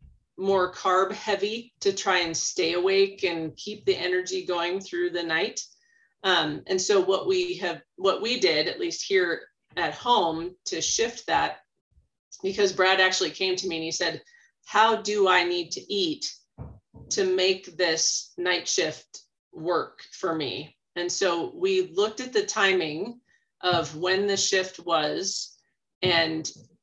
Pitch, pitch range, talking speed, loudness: 190 Hz, 175-235 Hz, 155 wpm, -25 LUFS